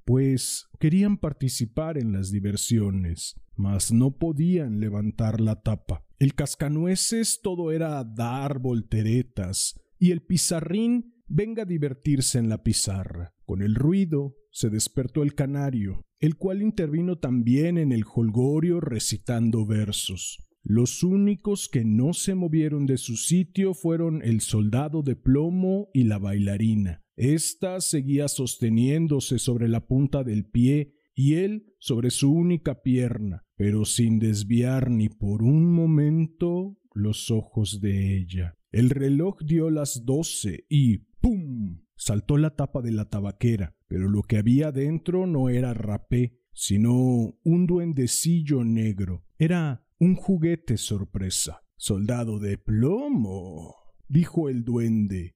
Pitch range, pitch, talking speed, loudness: 110-160 Hz, 125 Hz, 130 wpm, -25 LUFS